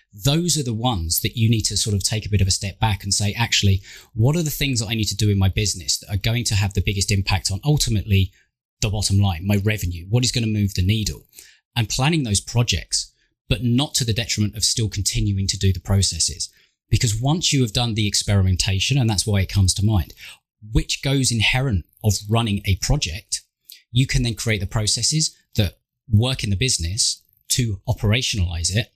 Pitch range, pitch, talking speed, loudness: 100-120 Hz, 105 Hz, 220 wpm, -21 LUFS